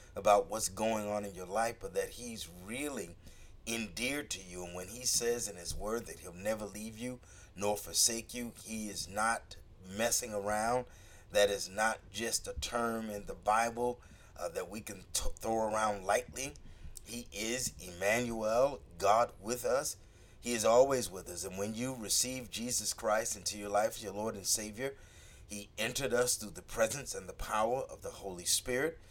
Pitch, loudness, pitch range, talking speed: 105 Hz, -35 LUFS, 95-120 Hz, 185 wpm